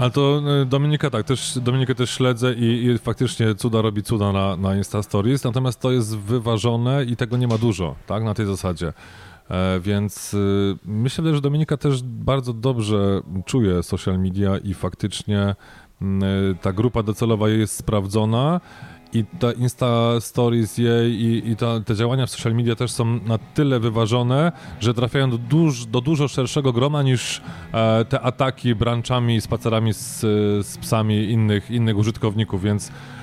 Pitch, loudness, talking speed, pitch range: 115 Hz, -21 LUFS, 160 wpm, 105-125 Hz